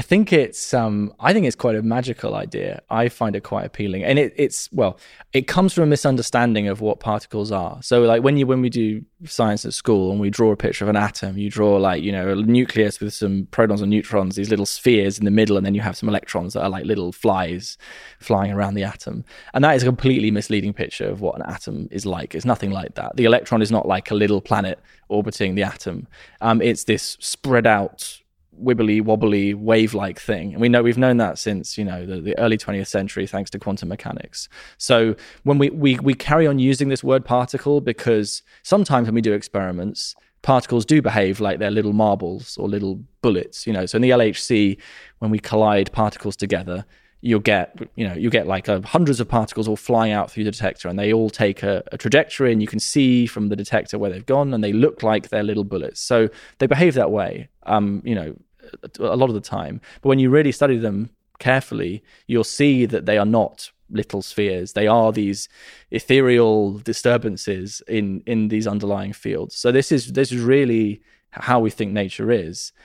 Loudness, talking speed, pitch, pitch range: -20 LUFS, 220 wpm, 110 Hz, 100-120 Hz